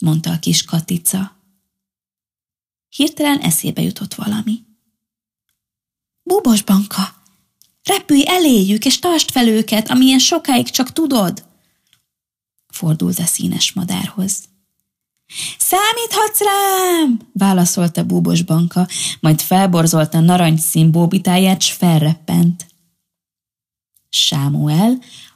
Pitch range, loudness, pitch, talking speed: 165-245 Hz, -15 LUFS, 190 Hz, 85 wpm